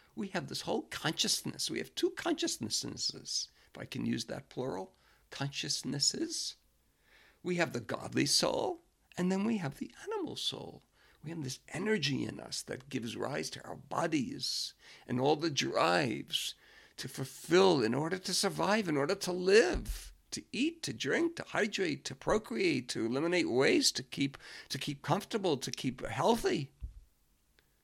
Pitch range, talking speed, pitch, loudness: 135-225 Hz, 155 wpm, 170 Hz, -33 LUFS